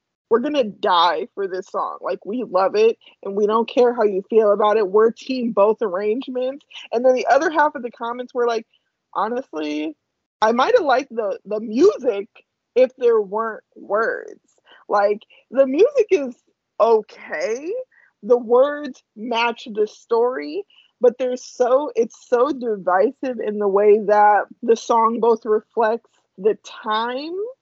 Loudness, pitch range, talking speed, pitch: -20 LUFS, 215-300 Hz, 155 wpm, 240 Hz